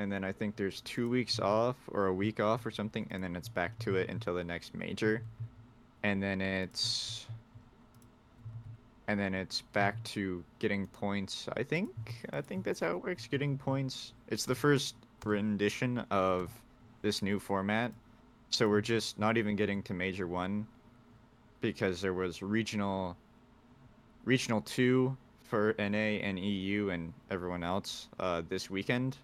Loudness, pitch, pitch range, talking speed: -34 LUFS, 110 Hz, 100-120 Hz, 160 wpm